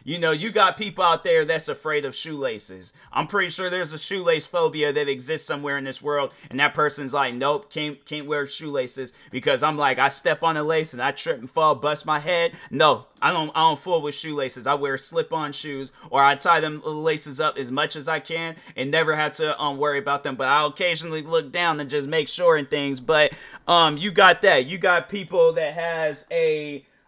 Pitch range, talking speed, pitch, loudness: 145-170 Hz, 225 wpm, 155 Hz, -22 LUFS